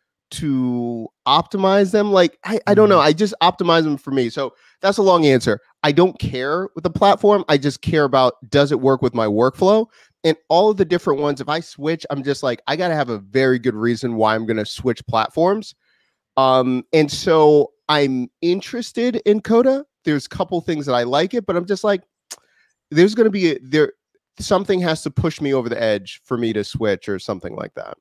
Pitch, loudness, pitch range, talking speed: 155 Hz, -18 LUFS, 130-195 Hz, 210 wpm